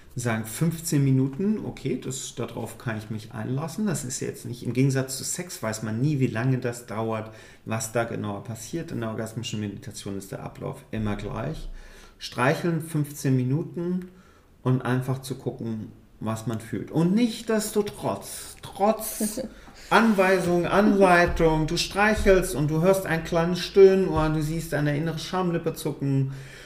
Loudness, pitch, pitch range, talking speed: -25 LUFS, 135 Hz, 115-175 Hz, 160 wpm